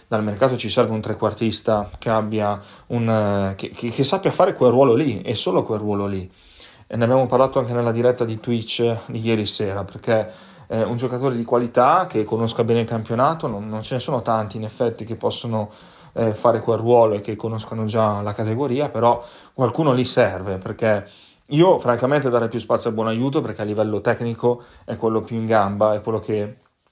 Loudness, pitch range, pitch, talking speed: -21 LUFS, 110-120 Hz, 115 Hz, 205 wpm